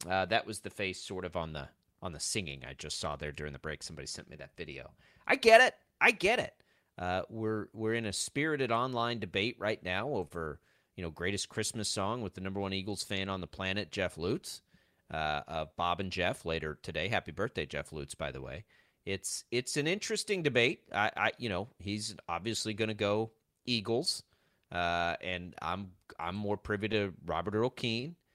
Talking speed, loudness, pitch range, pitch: 200 wpm, -33 LUFS, 90-115 Hz, 100 Hz